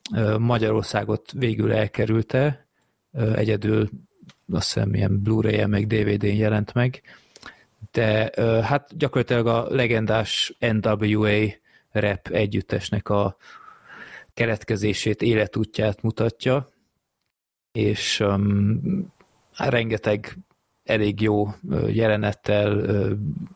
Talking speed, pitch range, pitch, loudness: 75 wpm, 105-115 Hz, 110 Hz, -23 LUFS